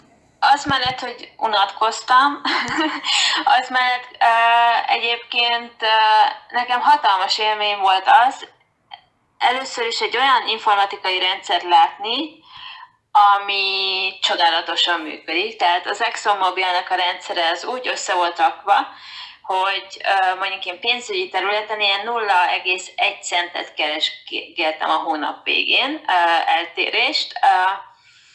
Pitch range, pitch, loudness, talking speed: 190-315 Hz, 220 Hz, -18 LUFS, 105 wpm